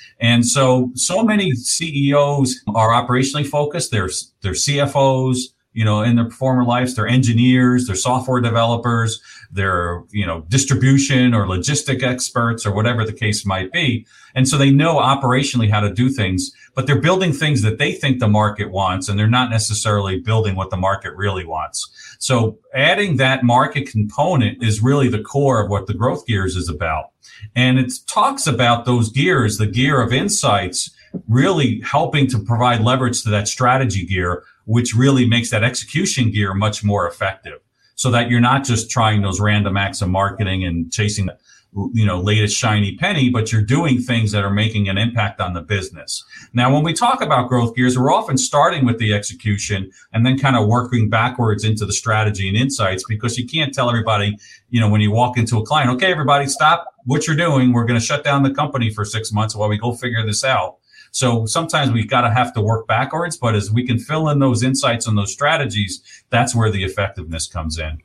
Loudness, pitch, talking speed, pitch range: -17 LUFS, 120 Hz, 195 wpm, 105-130 Hz